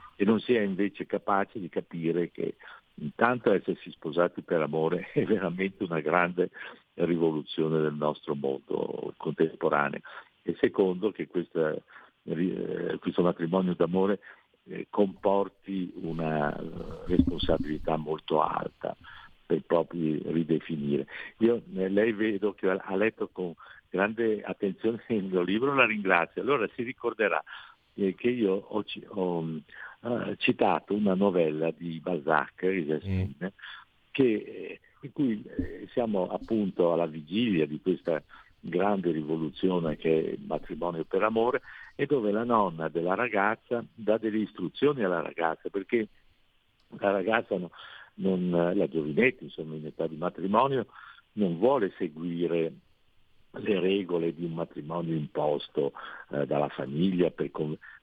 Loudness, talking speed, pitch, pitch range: -29 LUFS, 120 wpm, 90 Hz, 80-100 Hz